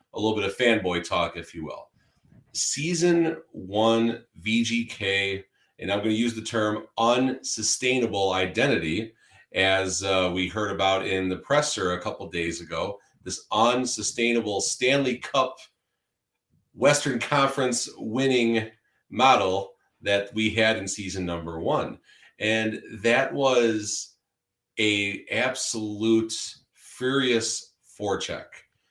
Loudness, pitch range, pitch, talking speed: -25 LUFS, 95-120 Hz, 110 Hz, 115 wpm